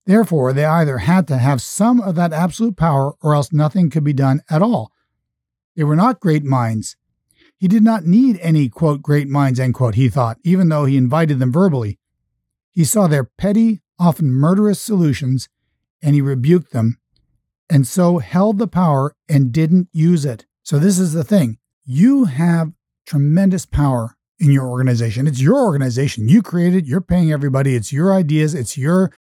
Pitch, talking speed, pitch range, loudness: 155 Hz, 180 wpm, 135-180 Hz, -16 LUFS